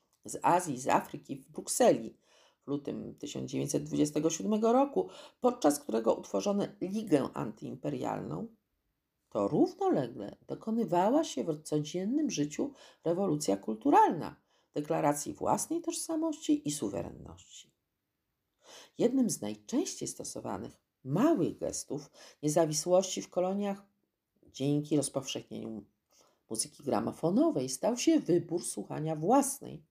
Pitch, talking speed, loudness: 175 Hz, 95 wpm, -32 LUFS